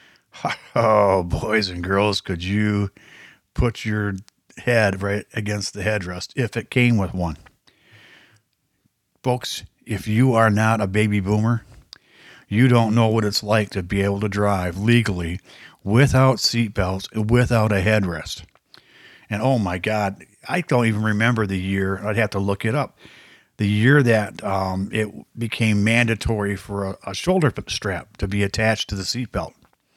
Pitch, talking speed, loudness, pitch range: 105 Hz, 155 wpm, -21 LUFS, 100-115 Hz